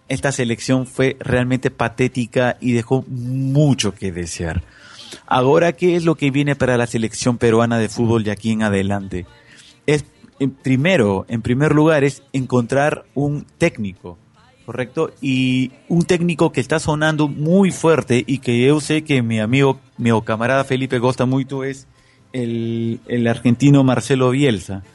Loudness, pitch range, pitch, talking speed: -18 LUFS, 115-140 Hz, 130 Hz, 150 wpm